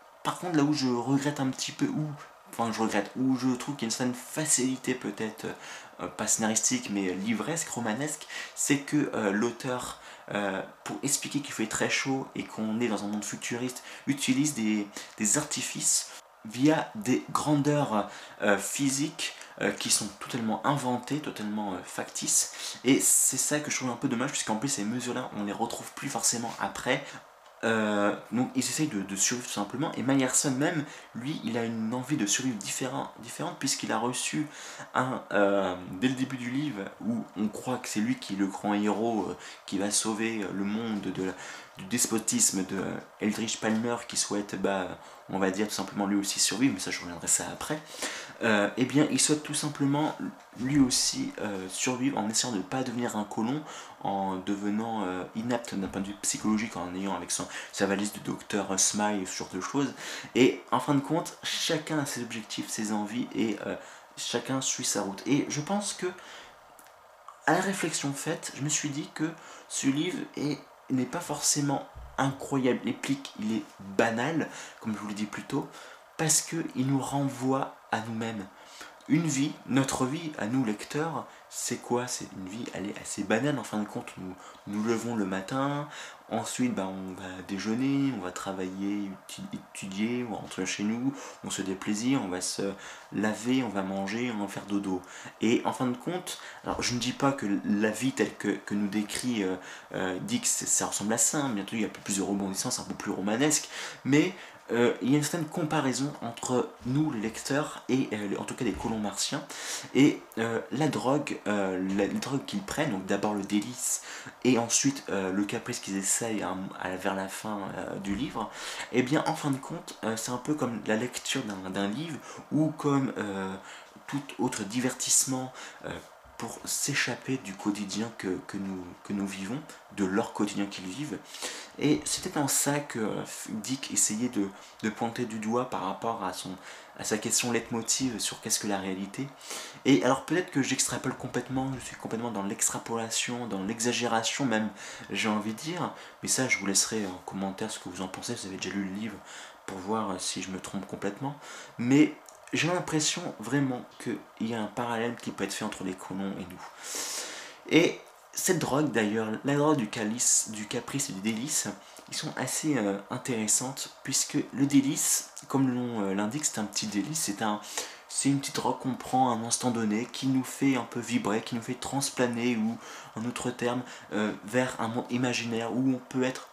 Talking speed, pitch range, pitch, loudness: 195 wpm, 100-135 Hz, 115 Hz, -30 LUFS